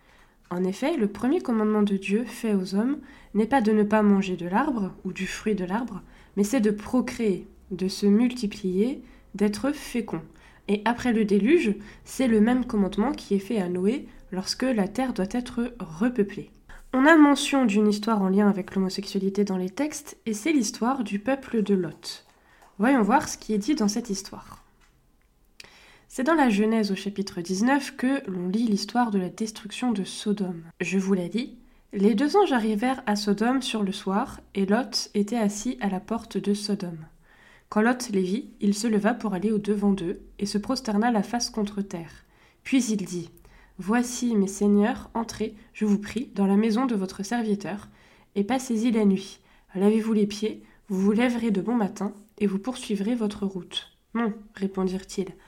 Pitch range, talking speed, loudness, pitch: 195-240 Hz, 185 wpm, -25 LUFS, 210 Hz